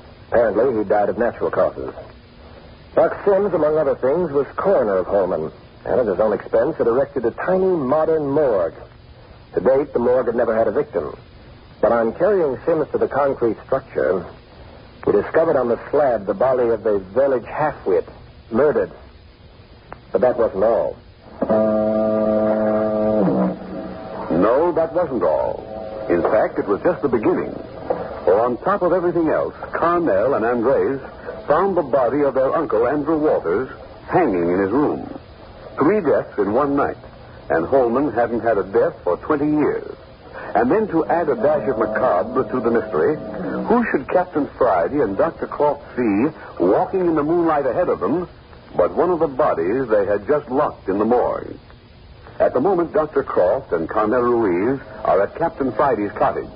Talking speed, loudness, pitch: 165 wpm, -19 LUFS, 170 Hz